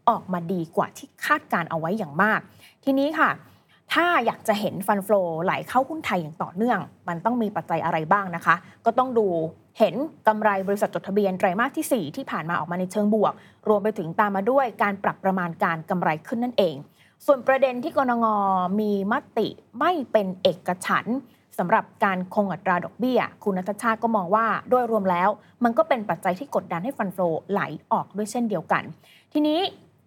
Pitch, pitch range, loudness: 210 Hz, 185-240 Hz, -24 LUFS